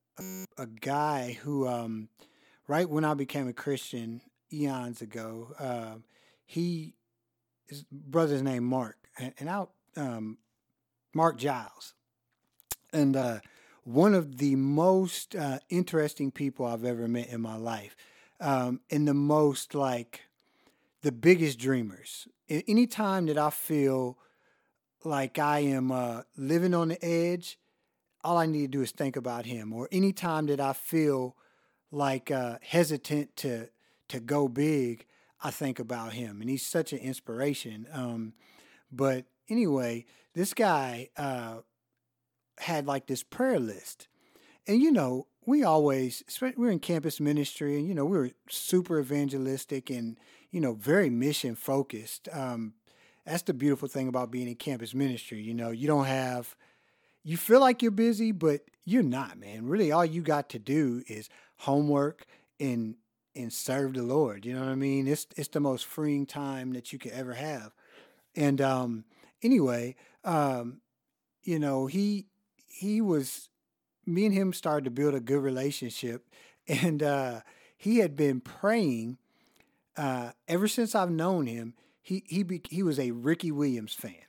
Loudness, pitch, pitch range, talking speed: -30 LUFS, 140 Hz, 125-165 Hz, 155 wpm